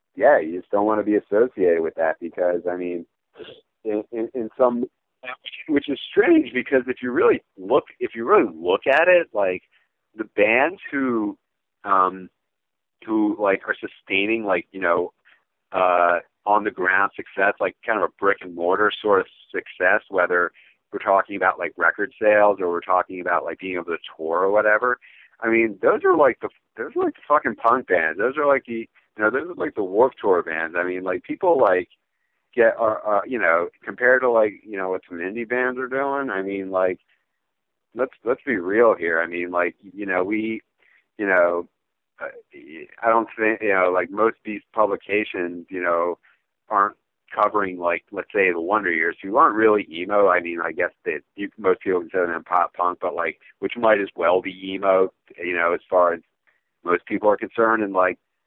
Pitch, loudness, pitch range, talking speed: 105 Hz, -21 LUFS, 90-125 Hz, 200 wpm